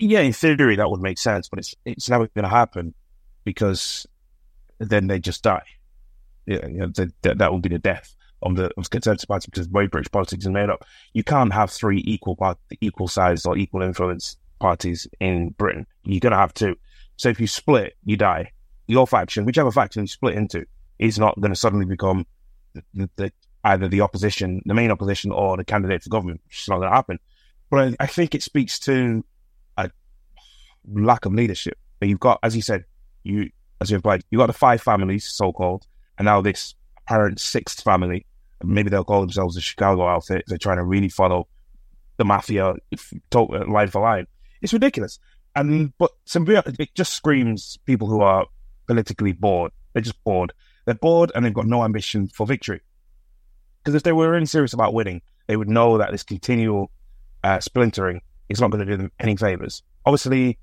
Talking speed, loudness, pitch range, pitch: 200 wpm, -21 LUFS, 95-115 Hz, 100 Hz